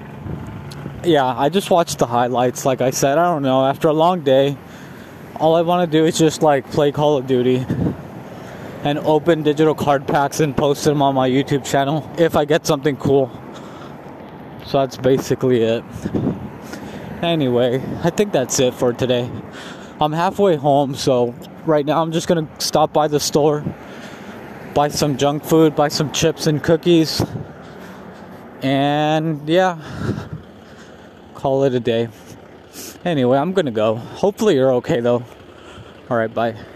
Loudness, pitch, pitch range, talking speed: -18 LUFS, 145 Hz, 130-160 Hz, 155 wpm